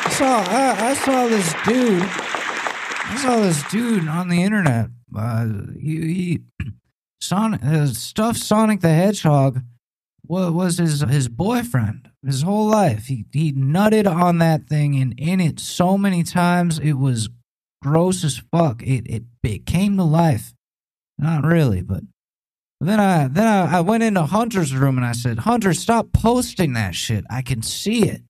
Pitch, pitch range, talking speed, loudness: 165 Hz, 130-200 Hz, 160 wpm, -19 LUFS